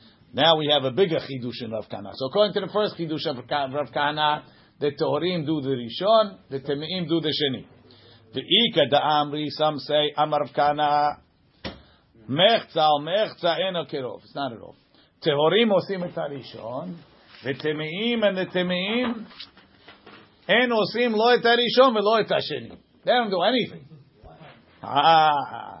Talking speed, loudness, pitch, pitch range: 140 wpm, -23 LUFS, 150 Hz, 140-190 Hz